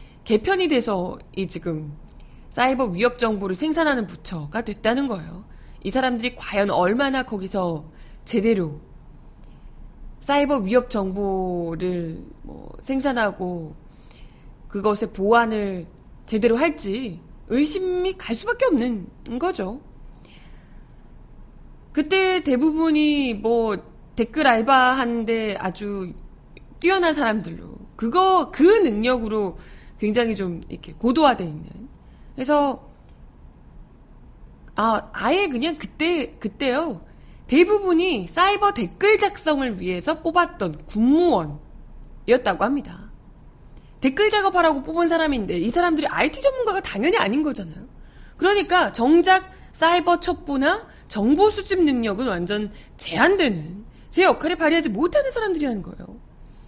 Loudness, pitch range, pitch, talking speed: -21 LUFS, 205-330 Hz, 255 Hz, 255 characters per minute